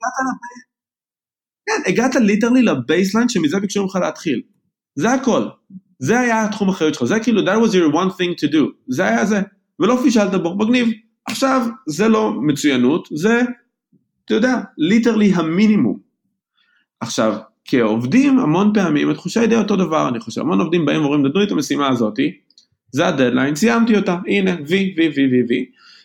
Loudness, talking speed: -17 LUFS, 160 wpm